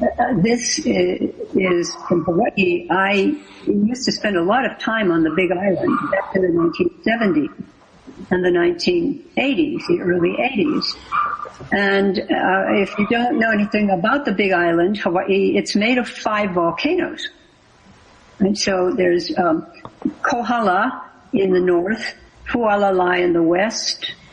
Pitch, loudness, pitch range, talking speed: 200 Hz, -18 LUFS, 180-245 Hz, 140 wpm